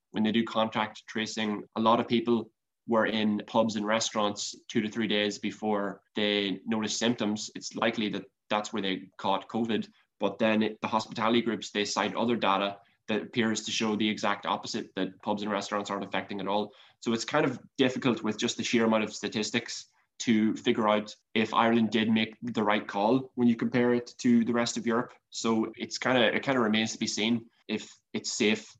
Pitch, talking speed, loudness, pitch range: 110 Hz, 210 wpm, -29 LUFS, 105-115 Hz